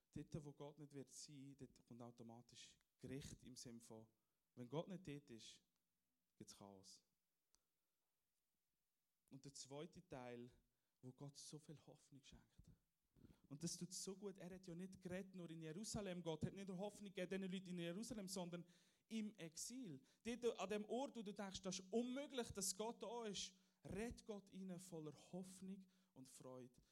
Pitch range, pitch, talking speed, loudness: 135-190 Hz, 170 Hz, 170 wpm, -53 LUFS